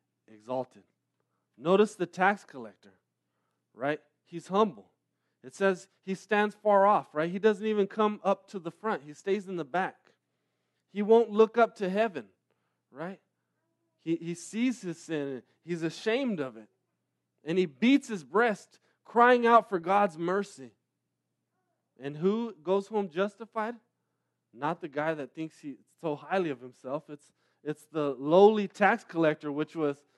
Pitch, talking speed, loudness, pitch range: 175 Hz, 155 wpm, -29 LUFS, 145-205 Hz